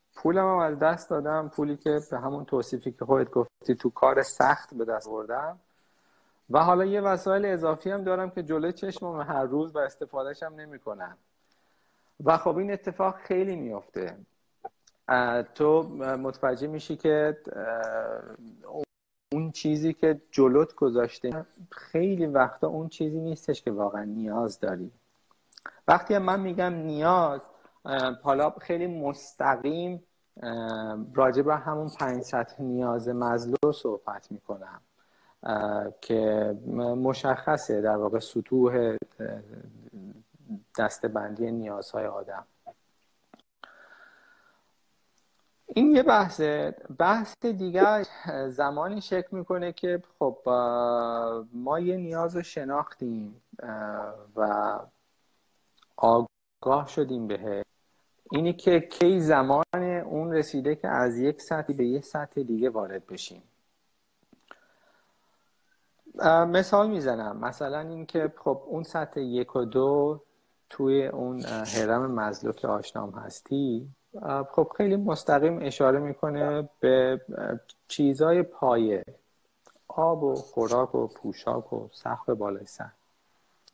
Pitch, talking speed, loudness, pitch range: 145 Hz, 110 wpm, -27 LUFS, 120-170 Hz